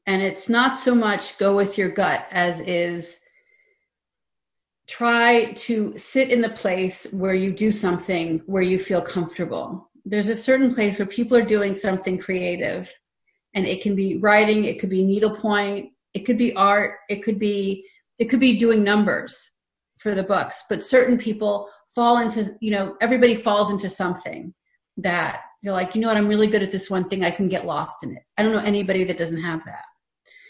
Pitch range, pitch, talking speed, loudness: 190-230 Hz, 205 Hz, 190 wpm, -21 LUFS